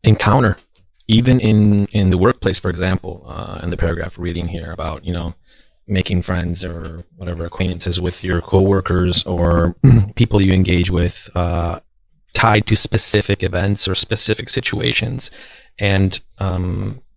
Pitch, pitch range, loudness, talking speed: 95 Hz, 90-105 Hz, -17 LUFS, 140 wpm